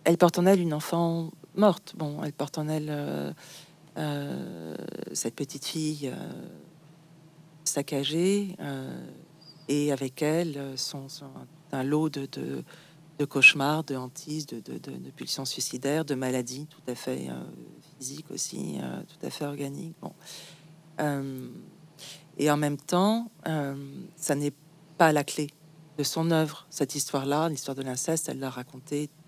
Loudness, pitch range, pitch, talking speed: -29 LUFS, 140-160 Hz, 150 Hz, 155 wpm